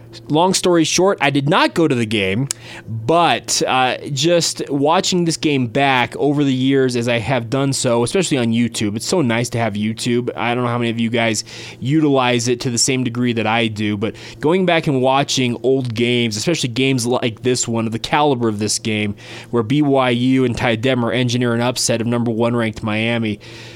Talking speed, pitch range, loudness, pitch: 205 wpm, 115-135 Hz, -17 LUFS, 120 Hz